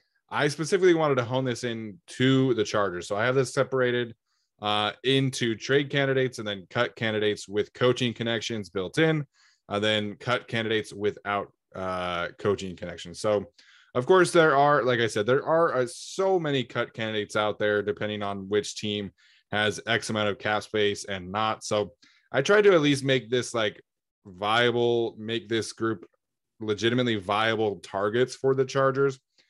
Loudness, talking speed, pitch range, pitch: -26 LUFS, 170 wpm, 105-130 Hz, 115 Hz